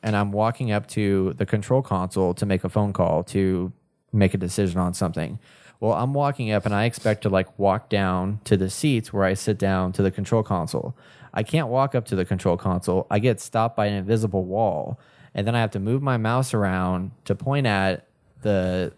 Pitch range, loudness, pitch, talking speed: 95-115 Hz, -24 LUFS, 100 Hz, 220 wpm